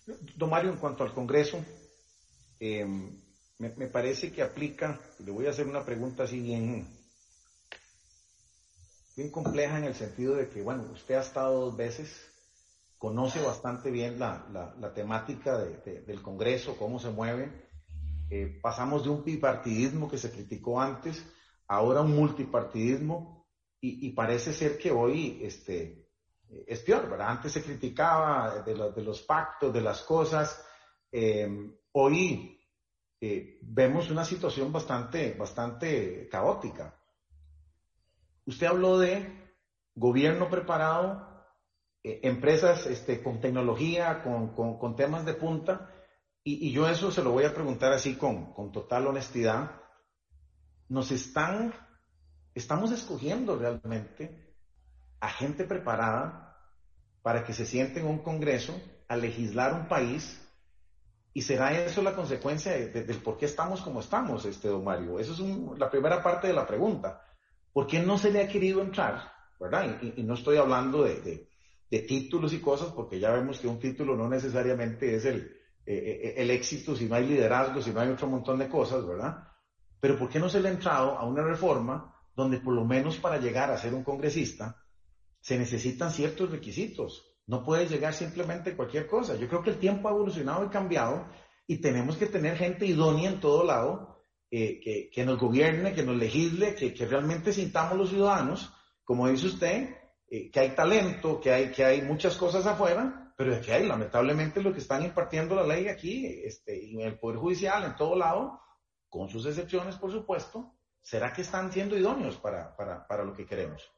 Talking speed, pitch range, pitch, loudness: 170 wpm, 115-165 Hz, 135 Hz, -30 LUFS